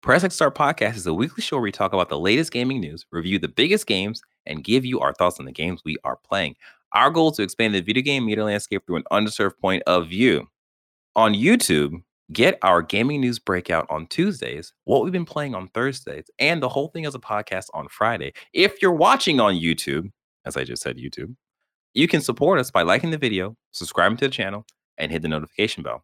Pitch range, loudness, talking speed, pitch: 85-130 Hz, -22 LUFS, 225 wpm, 105 Hz